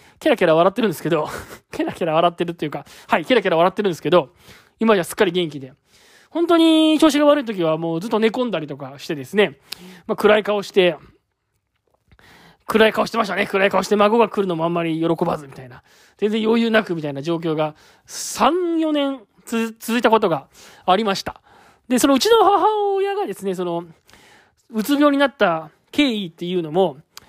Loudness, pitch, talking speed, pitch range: -19 LUFS, 200 Hz, 370 characters per minute, 170-235 Hz